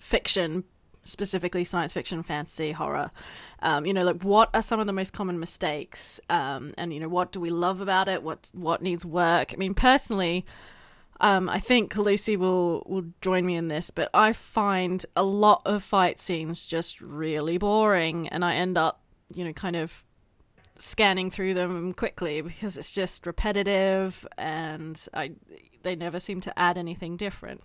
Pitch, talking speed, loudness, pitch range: 180 Hz, 175 wpm, -26 LUFS, 170-195 Hz